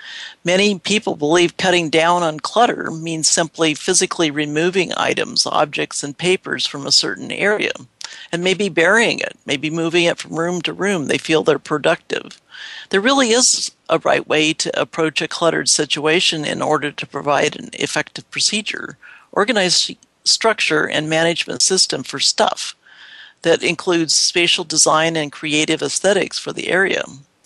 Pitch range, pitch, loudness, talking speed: 155-180 Hz, 165 Hz, -17 LUFS, 150 wpm